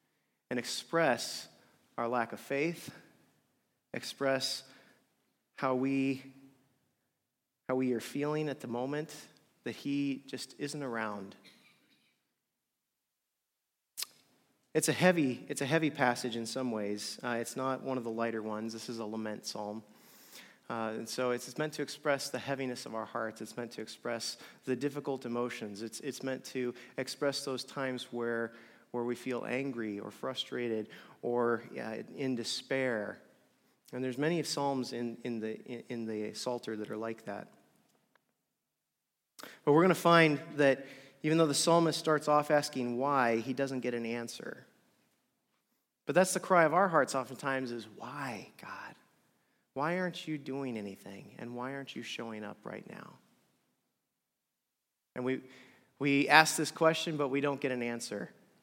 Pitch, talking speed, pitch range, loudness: 130 Hz, 155 wpm, 120-140 Hz, -34 LUFS